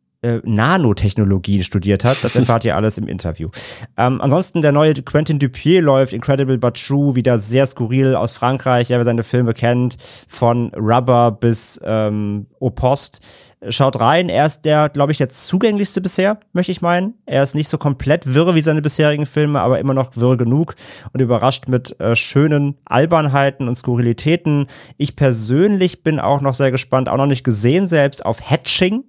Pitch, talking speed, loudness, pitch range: 130 Hz, 175 wpm, -16 LUFS, 120-150 Hz